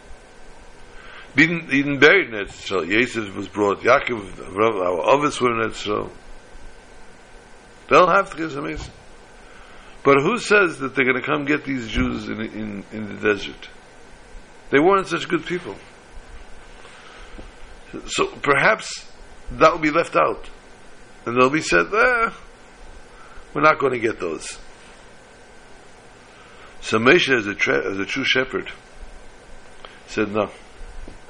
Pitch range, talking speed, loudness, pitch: 110-160 Hz, 135 wpm, -19 LUFS, 135 Hz